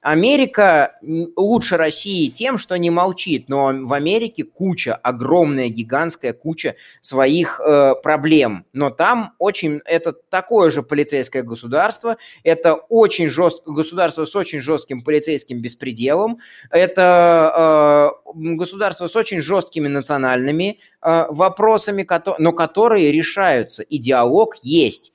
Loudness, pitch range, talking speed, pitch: -17 LUFS, 145-190 Hz, 115 wpm, 165 Hz